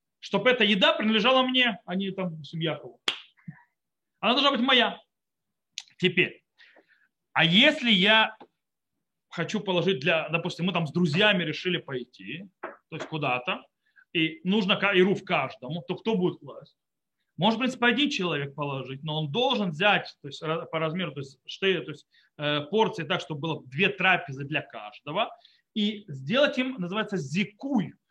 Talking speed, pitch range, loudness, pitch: 150 wpm, 160-215 Hz, -25 LUFS, 180 Hz